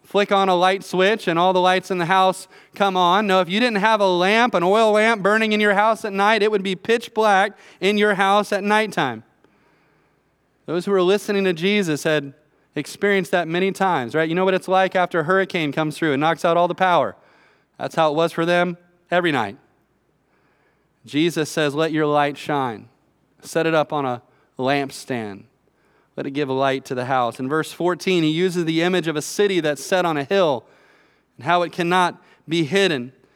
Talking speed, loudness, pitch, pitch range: 210 wpm, -19 LUFS, 175 Hz, 150-195 Hz